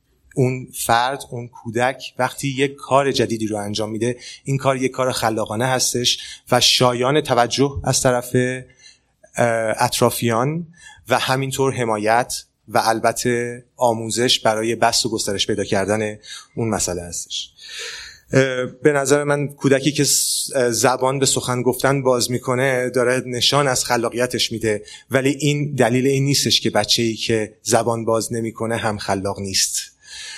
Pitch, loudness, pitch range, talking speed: 125 Hz, -19 LUFS, 115-130 Hz, 135 wpm